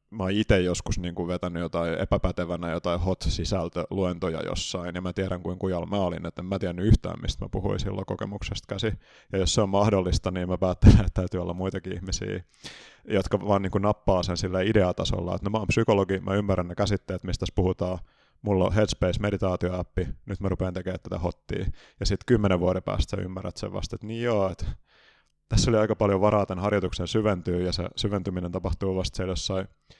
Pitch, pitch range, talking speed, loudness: 95 Hz, 90-100 Hz, 195 wpm, -27 LUFS